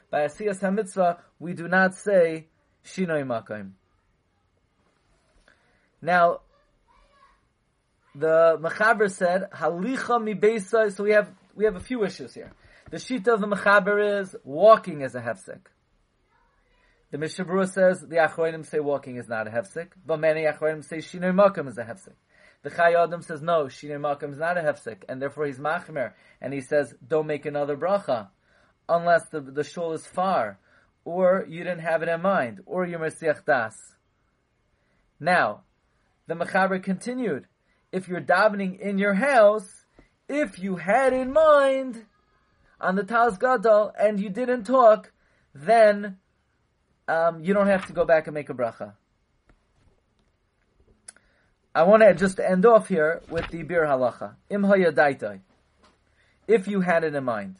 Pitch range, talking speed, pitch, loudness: 150-205 Hz, 145 wpm, 170 Hz, -23 LUFS